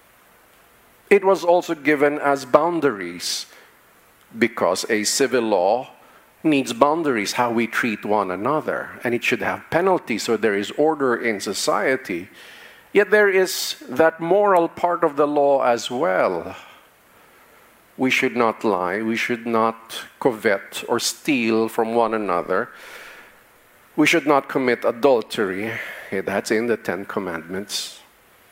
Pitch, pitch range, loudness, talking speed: 140 Hz, 115-170 Hz, -20 LUFS, 130 wpm